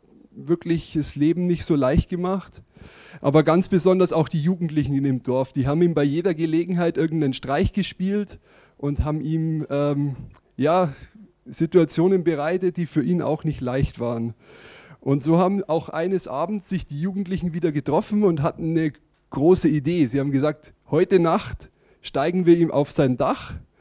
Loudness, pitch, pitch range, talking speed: -22 LUFS, 165 Hz, 145-180 Hz, 165 wpm